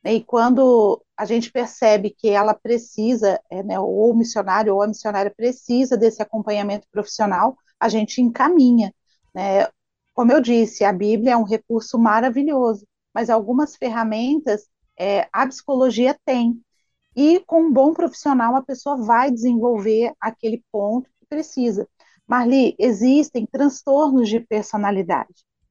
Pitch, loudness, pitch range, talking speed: 235 Hz, -19 LUFS, 215-260 Hz, 135 wpm